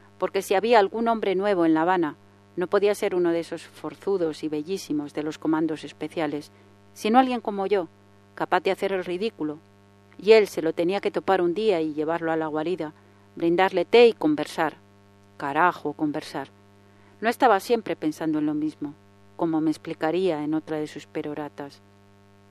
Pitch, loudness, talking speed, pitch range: 155 Hz, -24 LUFS, 175 wpm, 145-185 Hz